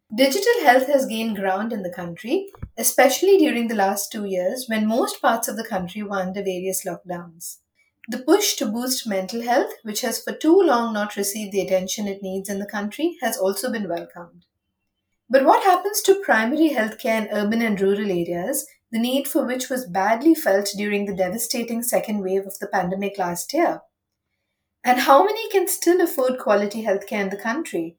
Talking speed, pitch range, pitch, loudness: 185 wpm, 195-265 Hz, 220 Hz, -21 LUFS